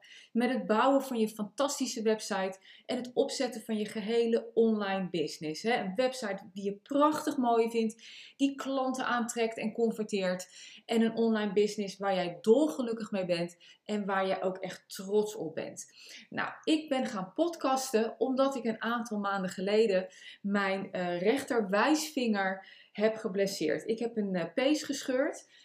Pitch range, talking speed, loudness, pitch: 195-250 Hz, 150 wpm, -31 LUFS, 220 Hz